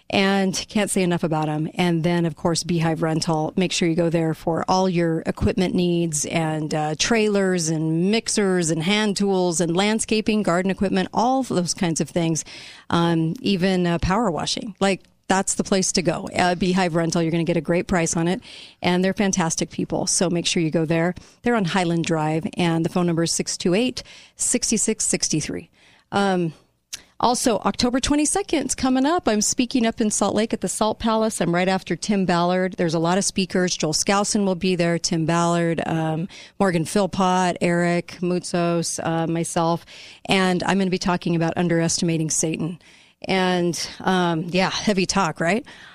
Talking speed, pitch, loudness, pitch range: 180 wpm, 180 Hz, -21 LUFS, 170-200 Hz